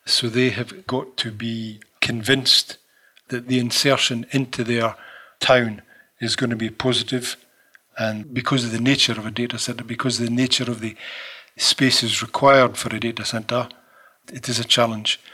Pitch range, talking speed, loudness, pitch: 115-130 Hz, 170 wpm, -20 LUFS, 120 Hz